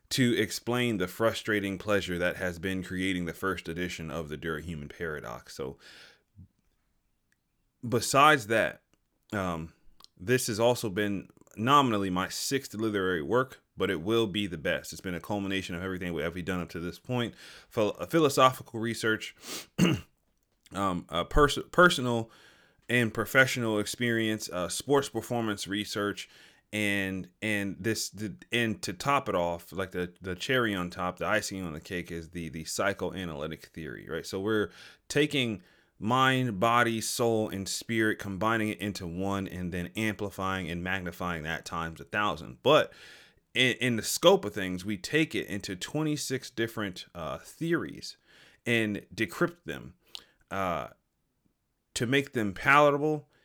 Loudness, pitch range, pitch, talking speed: -29 LUFS, 90-115 Hz, 105 Hz, 145 wpm